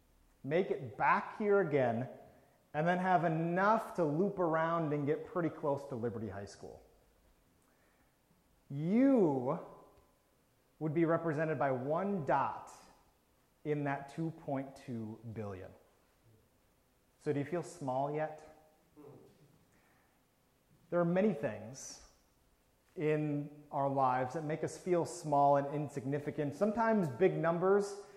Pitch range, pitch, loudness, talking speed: 135-170 Hz, 150 Hz, -34 LUFS, 115 wpm